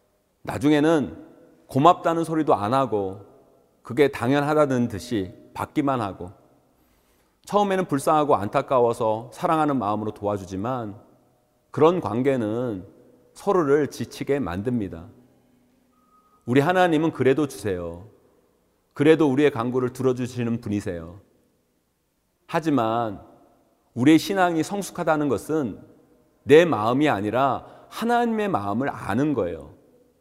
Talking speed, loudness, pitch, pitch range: 265 characters per minute, -23 LUFS, 135 Hz, 105-155 Hz